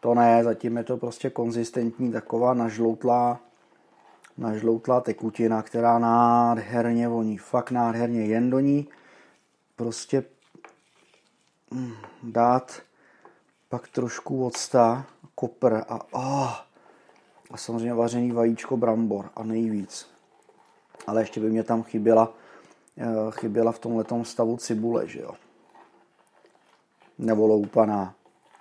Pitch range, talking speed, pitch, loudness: 115-120 Hz, 105 wpm, 115 Hz, -25 LUFS